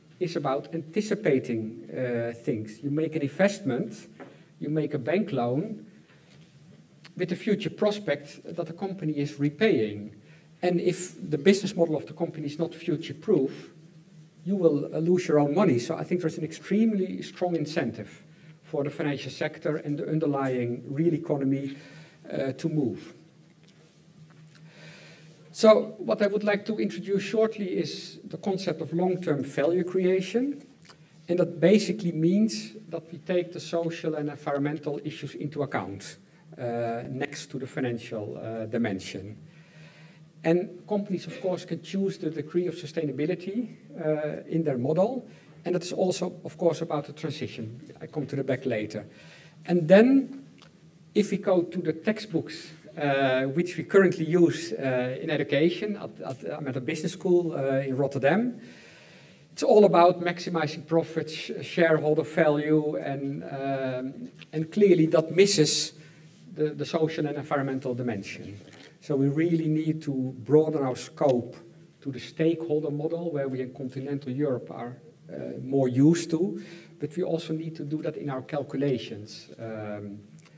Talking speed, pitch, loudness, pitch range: 150 wpm, 160 Hz, -27 LUFS, 145-175 Hz